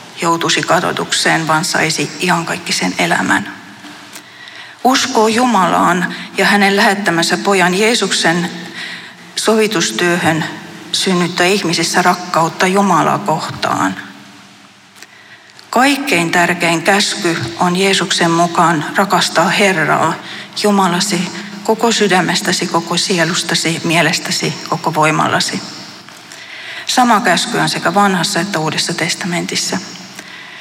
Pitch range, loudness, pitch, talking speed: 165-195 Hz, -13 LUFS, 175 Hz, 90 wpm